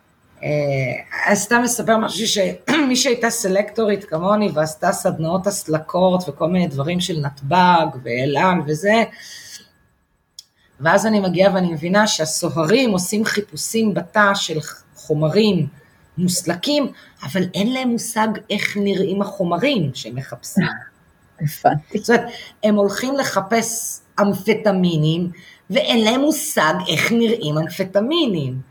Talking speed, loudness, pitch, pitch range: 105 wpm, -18 LUFS, 195 Hz, 160-220 Hz